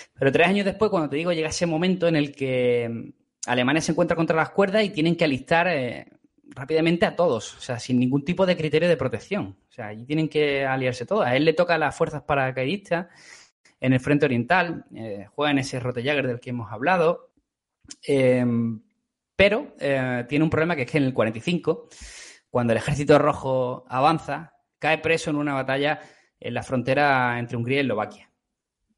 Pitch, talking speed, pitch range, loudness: 150 Hz, 195 wpm, 130-170 Hz, -23 LUFS